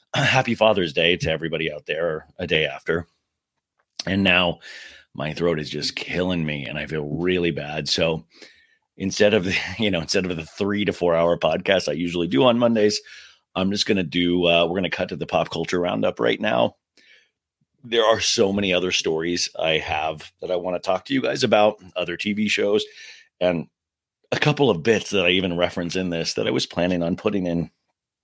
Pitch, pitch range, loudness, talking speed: 90 Hz, 85-105 Hz, -22 LUFS, 200 wpm